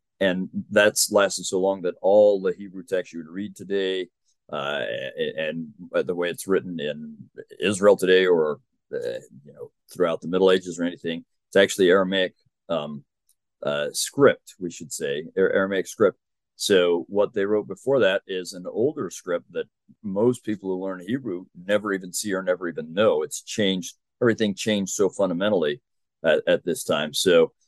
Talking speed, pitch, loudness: 175 wpm, 100 Hz, -23 LUFS